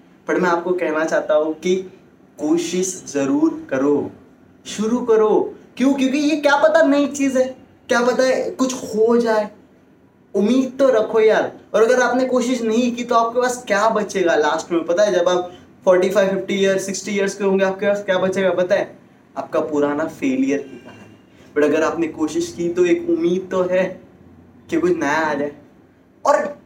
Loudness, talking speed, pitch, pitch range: -18 LUFS, 185 wpm, 200 Hz, 170-255 Hz